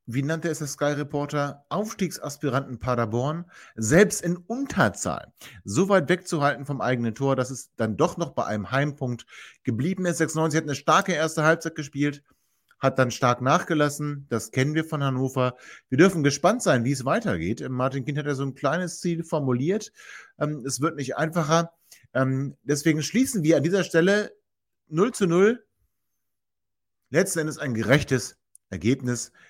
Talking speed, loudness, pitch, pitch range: 155 wpm, -25 LUFS, 145 Hz, 130-170 Hz